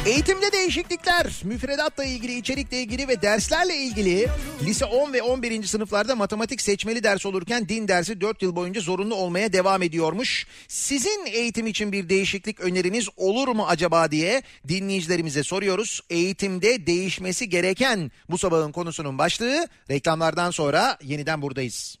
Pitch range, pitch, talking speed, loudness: 175-245 Hz, 200 Hz, 135 wpm, -24 LUFS